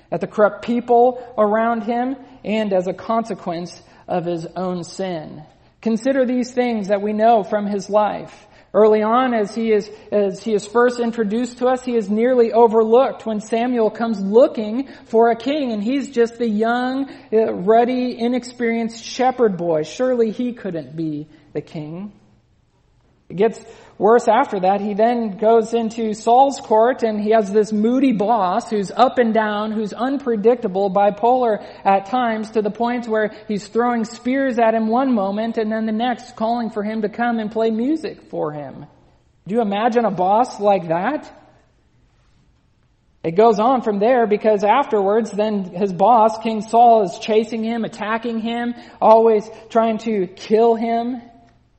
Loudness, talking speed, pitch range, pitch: -18 LUFS, 165 wpm, 210-240 Hz, 225 Hz